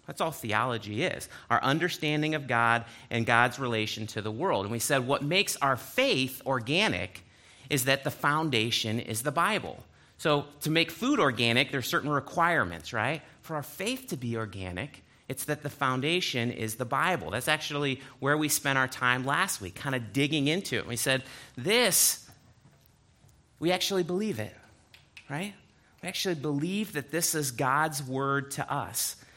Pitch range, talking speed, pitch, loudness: 120-155 Hz, 170 wpm, 140 Hz, -28 LUFS